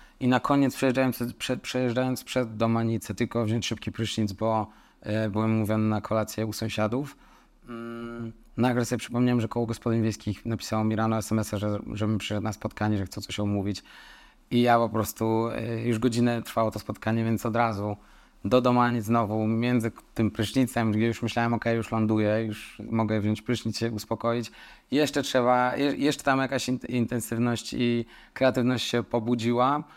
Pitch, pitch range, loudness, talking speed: 115 Hz, 110-120 Hz, -27 LUFS, 180 wpm